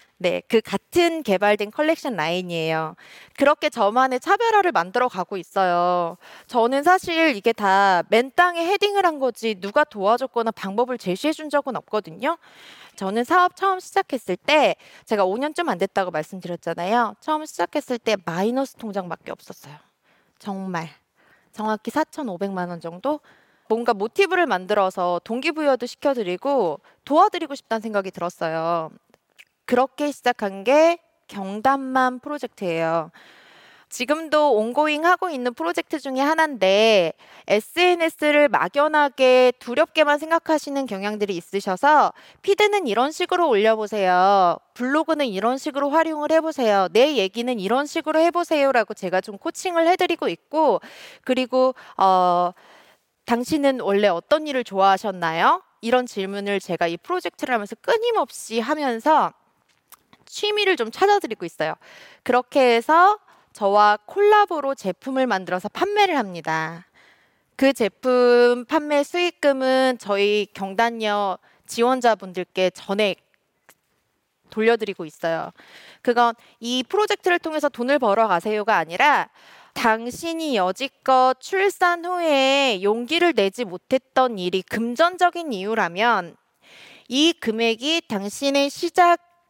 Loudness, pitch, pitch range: -21 LUFS, 245 Hz, 200-305 Hz